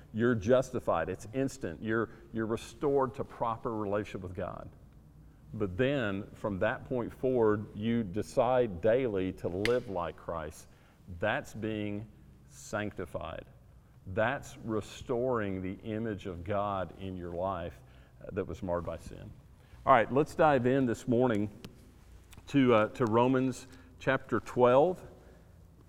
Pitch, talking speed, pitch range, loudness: 110 Hz, 125 wpm, 100-125 Hz, -32 LUFS